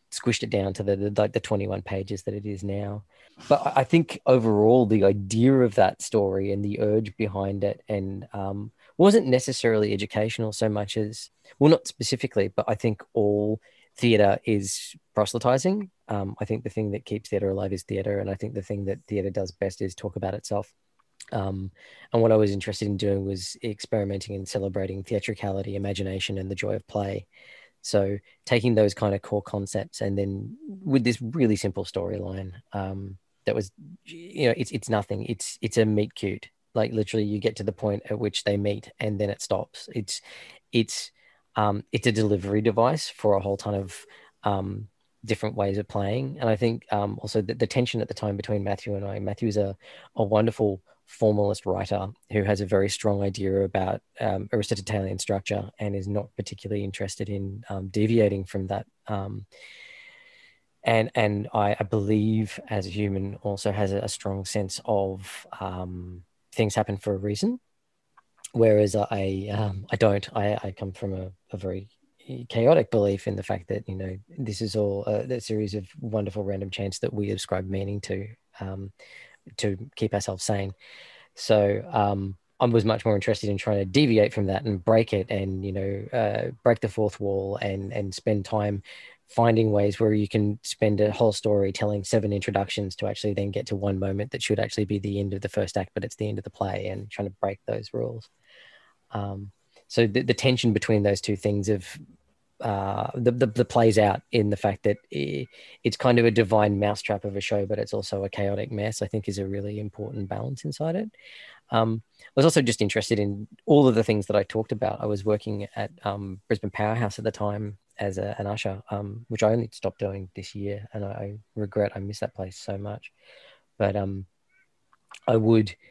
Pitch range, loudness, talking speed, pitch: 100-110 Hz, -26 LUFS, 200 wpm, 105 Hz